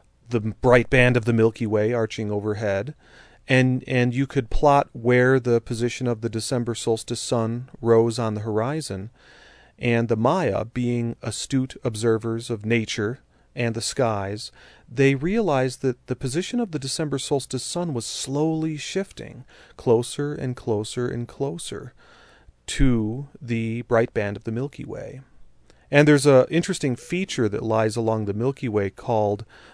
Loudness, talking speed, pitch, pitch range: -23 LUFS, 150 wpm, 120 Hz, 115-135 Hz